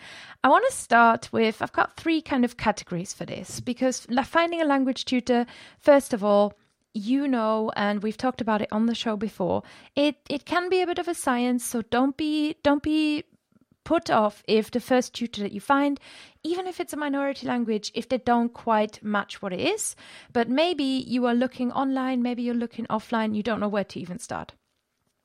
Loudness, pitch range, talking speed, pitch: -25 LUFS, 220-280 Hz, 205 wpm, 245 Hz